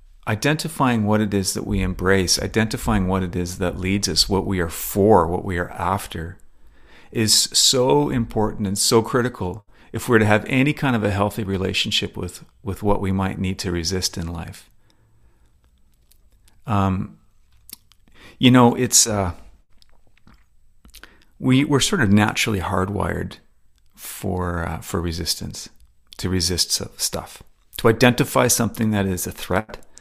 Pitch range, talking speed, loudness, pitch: 90-110 Hz, 145 wpm, -20 LUFS, 100 Hz